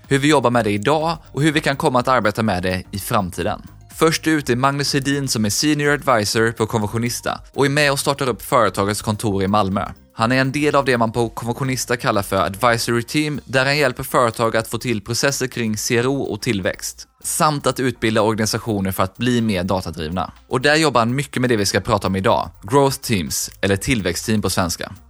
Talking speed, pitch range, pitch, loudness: 215 wpm, 105-135 Hz, 120 Hz, -19 LUFS